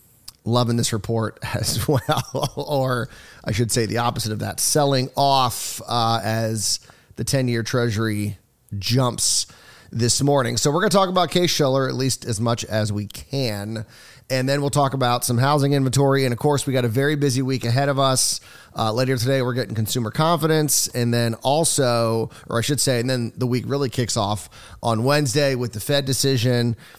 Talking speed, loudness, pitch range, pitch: 190 wpm, -21 LUFS, 115-140 Hz, 125 Hz